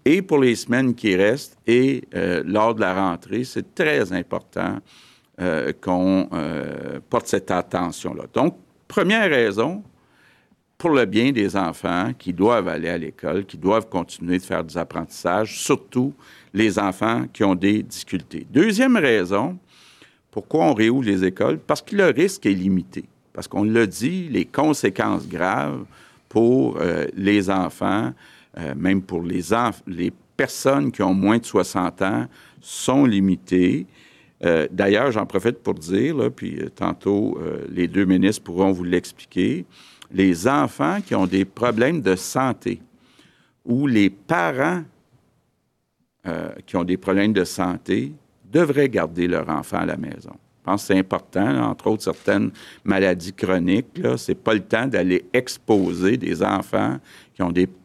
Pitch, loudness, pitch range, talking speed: 95 Hz, -21 LUFS, 90-115 Hz, 160 wpm